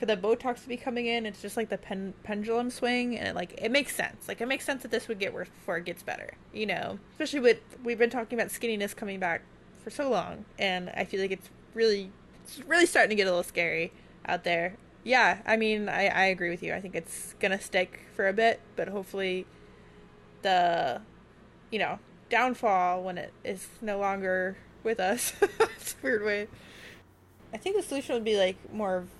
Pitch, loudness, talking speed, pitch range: 210 Hz, -29 LUFS, 215 wpm, 185-235 Hz